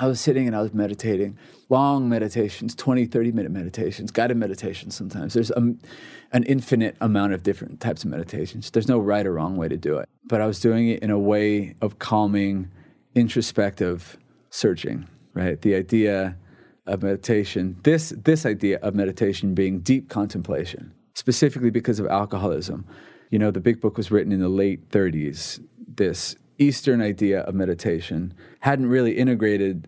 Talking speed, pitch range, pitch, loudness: 165 wpm, 100-120 Hz, 105 Hz, -23 LUFS